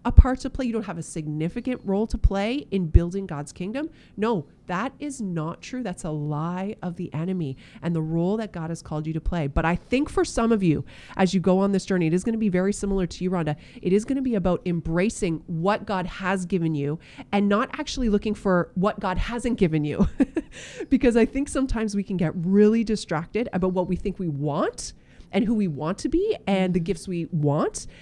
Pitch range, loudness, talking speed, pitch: 170-225 Hz, -25 LUFS, 230 wpm, 190 Hz